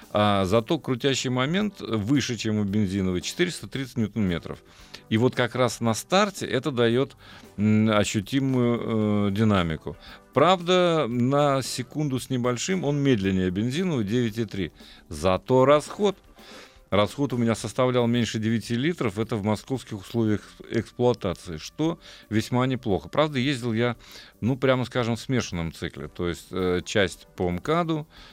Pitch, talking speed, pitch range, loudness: 115 Hz, 135 wpm, 100-130 Hz, -25 LUFS